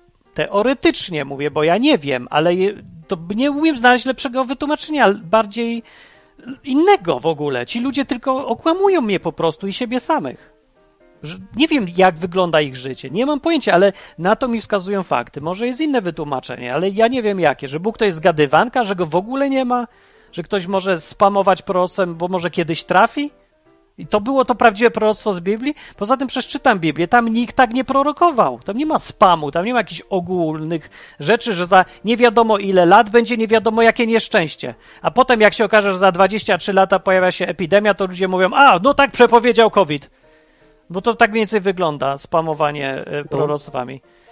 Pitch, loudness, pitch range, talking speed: 200 Hz, -17 LUFS, 170-245 Hz, 185 wpm